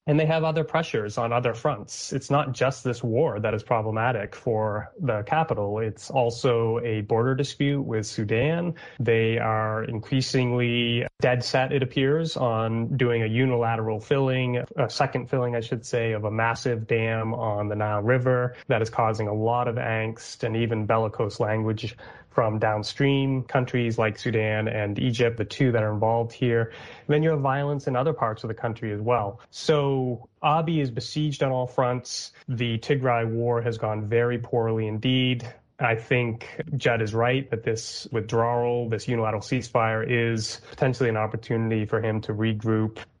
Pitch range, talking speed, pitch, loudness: 110-130 Hz, 170 wpm, 120 Hz, -25 LUFS